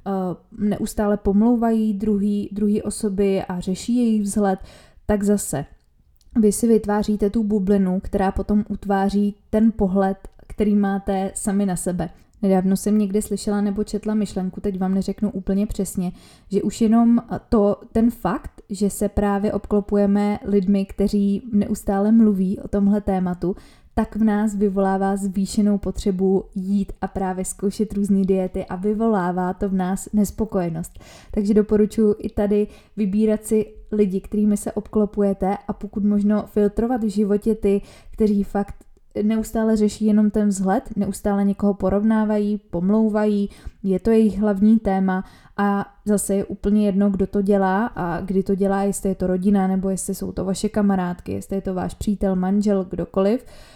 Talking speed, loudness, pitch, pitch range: 150 wpm, -21 LUFS, 205 Hz, 195-210 Hz